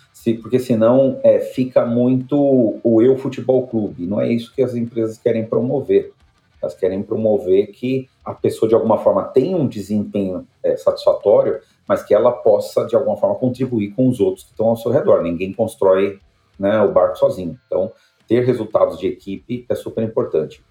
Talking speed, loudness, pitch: 175 wpm, -18 LUFS, 125 Hz